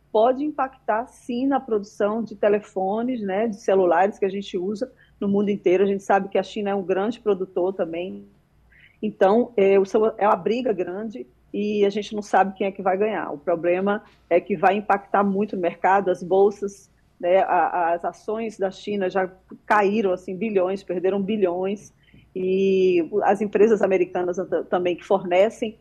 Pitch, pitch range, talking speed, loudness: 200 Hz, 185-215 Hz, 165 wpm, -22 LUFS